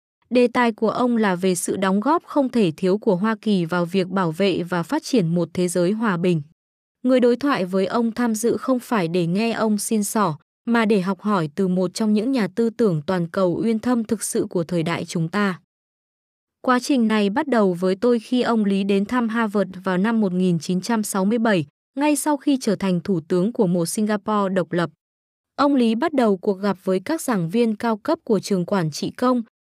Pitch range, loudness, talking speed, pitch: 185-235 Hz, -21 LUFS, 220 wpm, 210 Hz